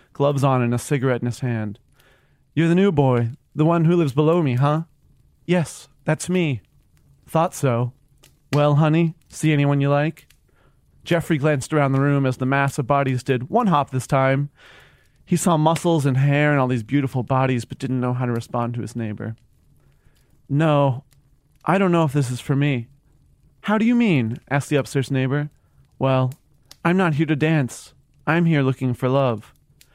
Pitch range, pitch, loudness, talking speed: 130-155 Hz, 140 Hz, -21 LUFS, 185 wpm